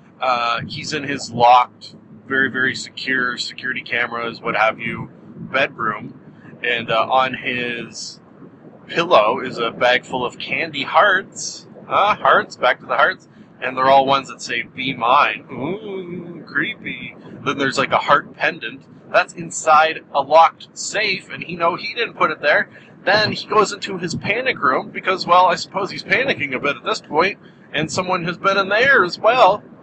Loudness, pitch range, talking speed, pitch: -18 LUFS, 125-185 Hz, 175 wpm, 155 Hz